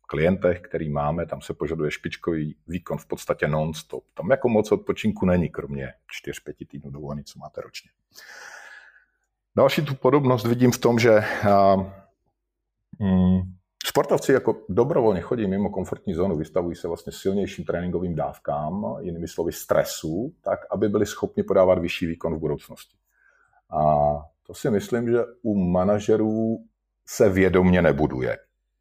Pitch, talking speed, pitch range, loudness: 90 Hz, 135 wpm, 75-105 Hz, -23 LUFS